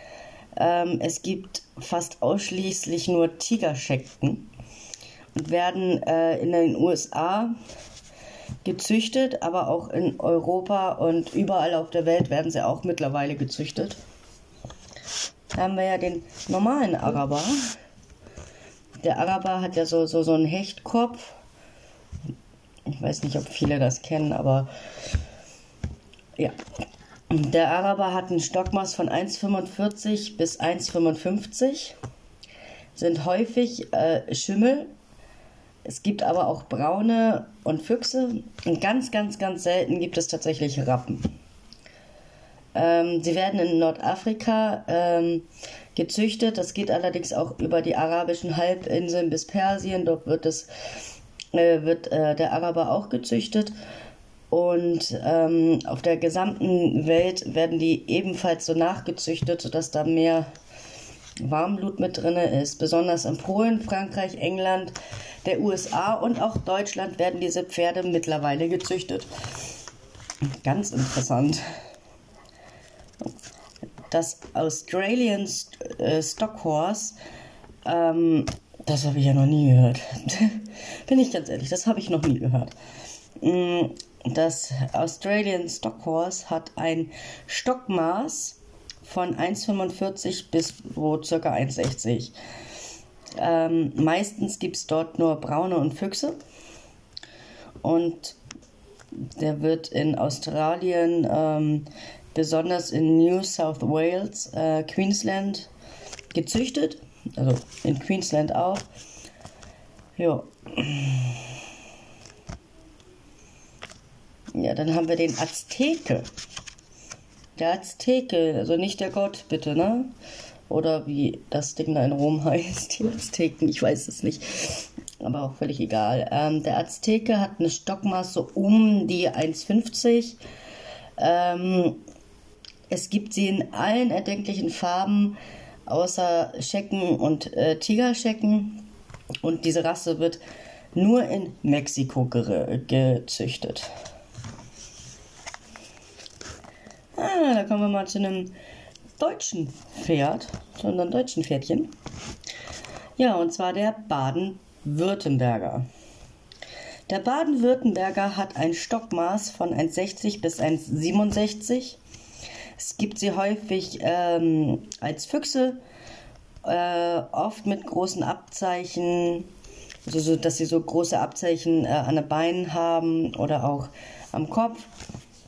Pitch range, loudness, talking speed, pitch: 155-195 Hz, -25 LUFS, 110 wpm, 170 Hz